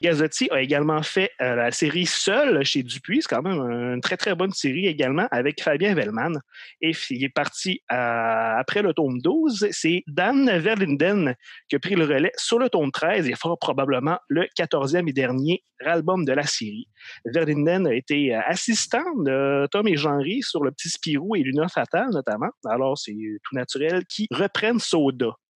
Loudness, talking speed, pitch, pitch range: -23 LUFS, 185 wpm, 160 Hz, 135-190 Hz